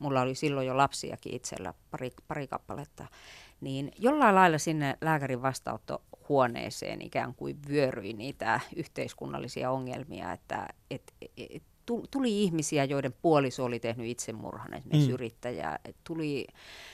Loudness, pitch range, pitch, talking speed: -31 LUFS, 125-155 Hz, 140 Hz, 125 wpm